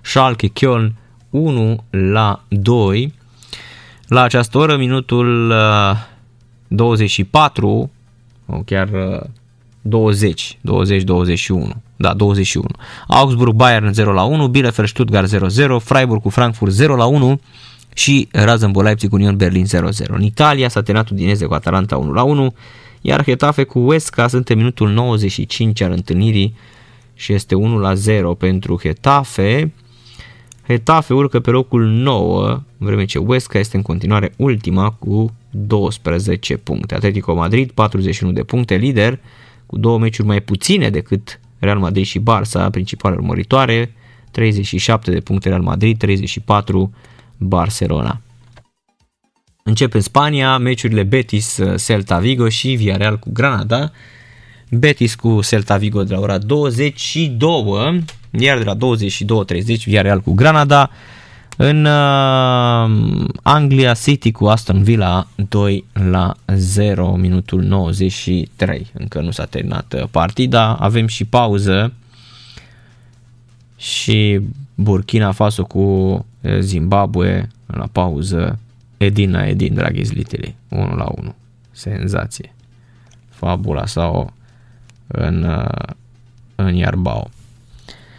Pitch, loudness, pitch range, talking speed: 115 Hz, -15 LUFS, 100-120 Hz, 120 wpm